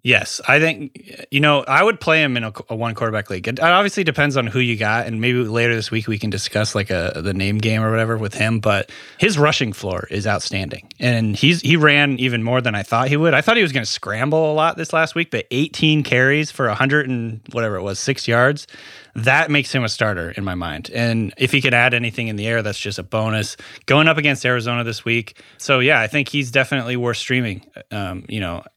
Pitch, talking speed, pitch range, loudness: 120 Hz, 245 wpm, 110-145 Hz, -18 LUFS